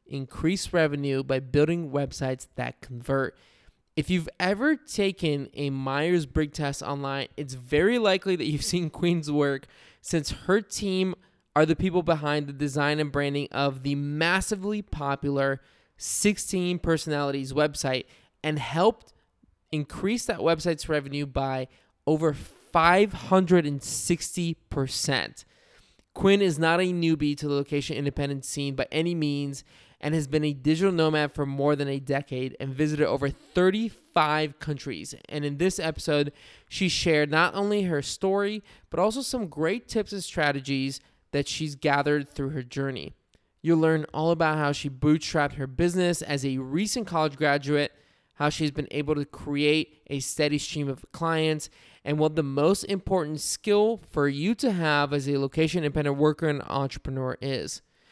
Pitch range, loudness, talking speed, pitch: 140-170 Hz, -26 LUFS, 150 wpm, 150 Hz